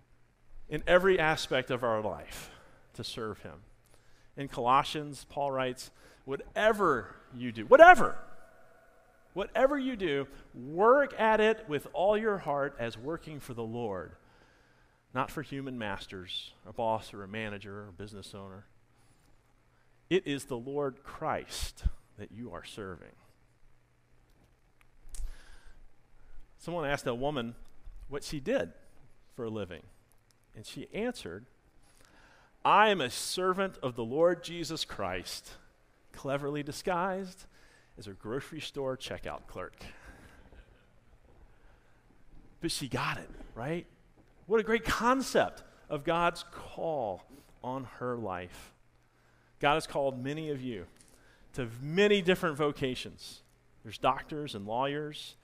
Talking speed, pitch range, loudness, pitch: 120 wpm, 105-155 Hz, -31 LUFS, 130 Hz